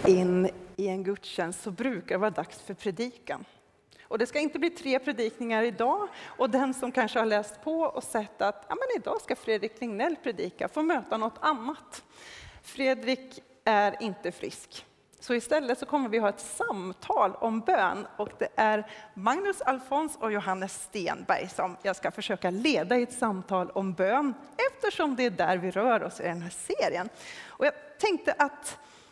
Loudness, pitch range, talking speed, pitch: -29 LUFS, 200-285 Hz, 180 wpm, 230 Hz